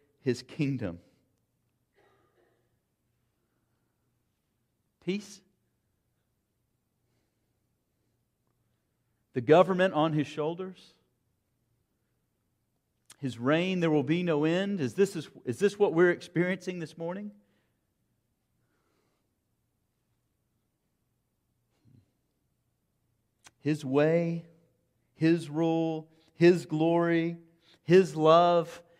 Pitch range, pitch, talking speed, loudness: 120-170 Hz, 150 Hz, 65 wpm, -27 LUFS